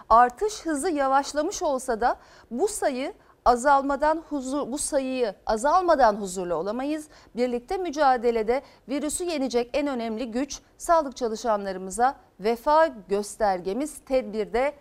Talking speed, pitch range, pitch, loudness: 105 wpm, 235-300 Hz, 270 Hz, -25 LUFS